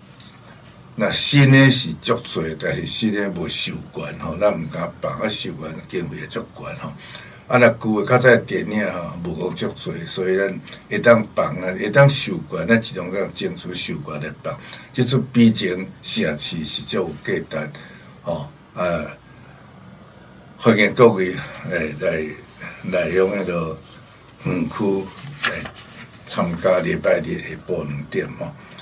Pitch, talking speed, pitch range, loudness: 105 Hz, 210 characters per minute, 90-120 Hz, -20 LUFS